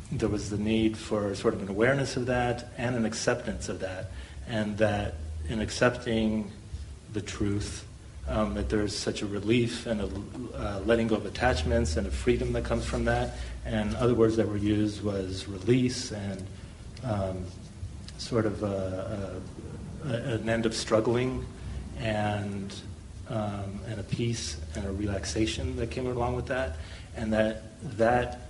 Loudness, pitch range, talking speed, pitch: -30 LUFS, 95-115 Hz, 160 wpm, 105 Hz